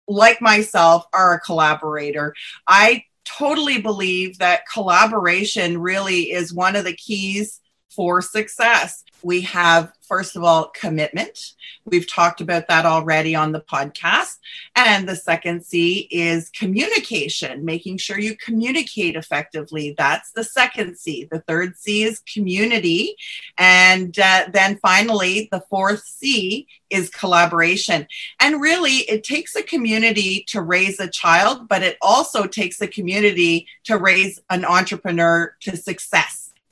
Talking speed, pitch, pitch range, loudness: 135 wpm, 190 Hz, 170-215 Hz, -17 LUFS